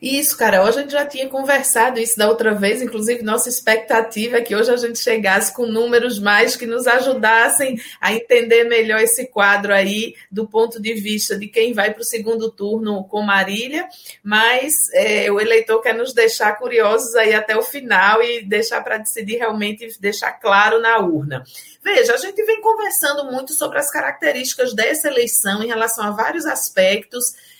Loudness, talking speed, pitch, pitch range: -16 LUFS, 180 wpm, 230 Hz, 215-260 Hz